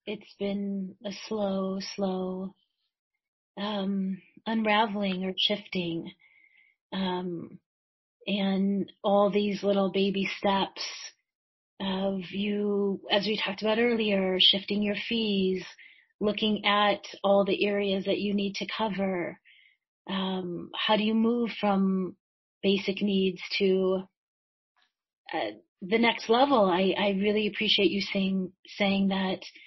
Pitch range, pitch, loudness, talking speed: 190-210 Hz, 200 Hz, -28 LUFS, 115 wpm